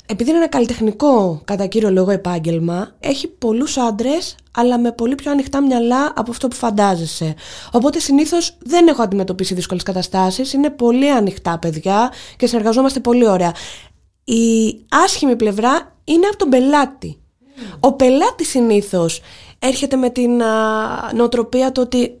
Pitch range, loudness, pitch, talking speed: 205-275 Hz, -16 LUFS, 240 Hz, 140 wpm